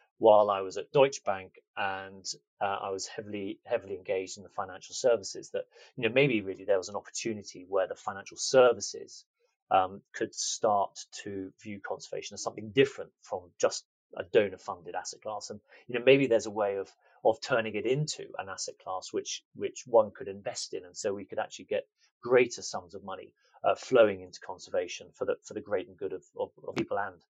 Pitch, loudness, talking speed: 395 Hz, -31 LUFS, 200 wpm